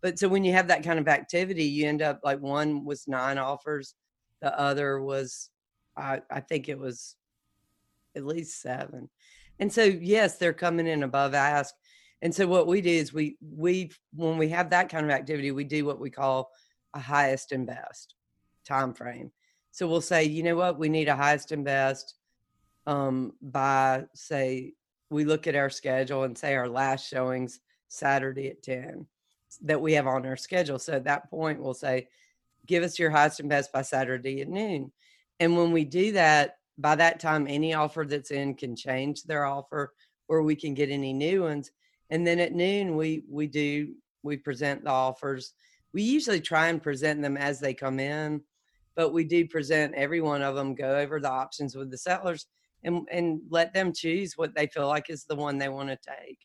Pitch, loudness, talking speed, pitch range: 145 Hz, -28 LUFS, 200 wpm, 135-165 Hz